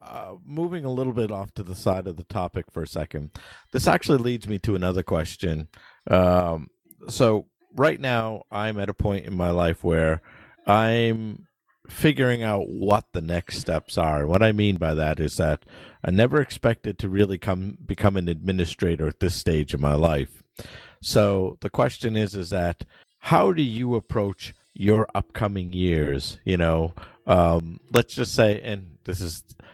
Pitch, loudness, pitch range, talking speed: 95 Hz, -24 LUFS, 85-110 Hz, 175 wpm